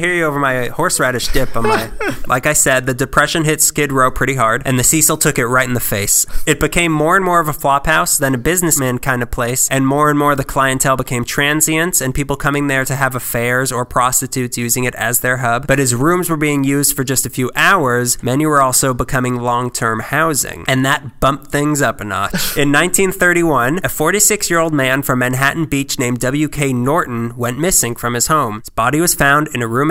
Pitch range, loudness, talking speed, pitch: 125-150 Hz, -14 LUFS, 225 wpm, 135 Hz